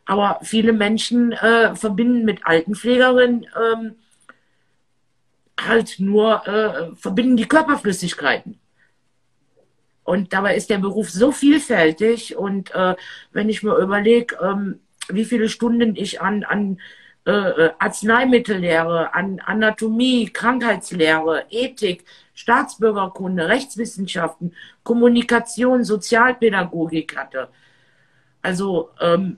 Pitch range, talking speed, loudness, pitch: 185-235 Hz, 95 wpm, -18 LUFS, 215 Hz